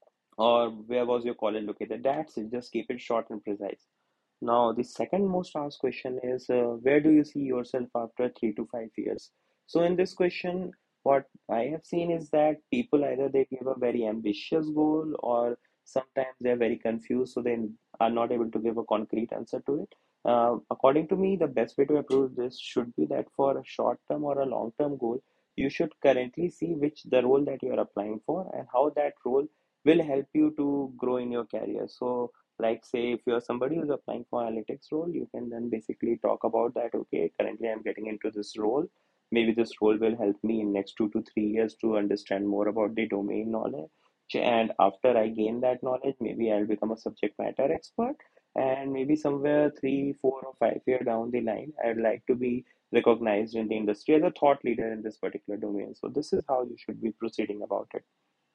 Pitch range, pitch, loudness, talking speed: 110-140 Hz, 120 Hz, -29 LUFS, 215 wpm